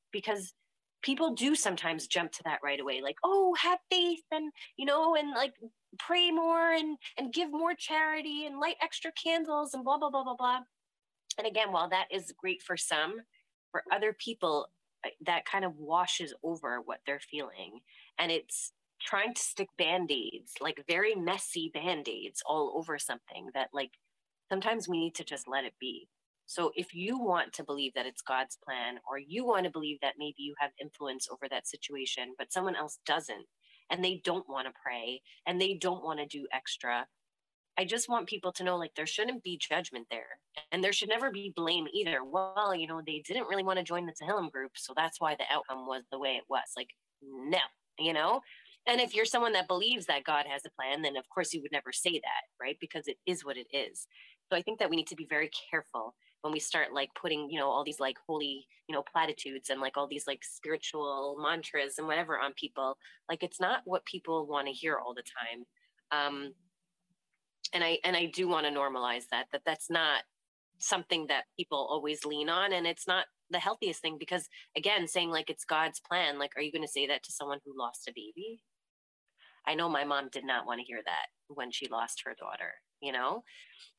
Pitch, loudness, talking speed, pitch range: 170 Hz, -33 LUFS, 215 wpm, 145-215 Hz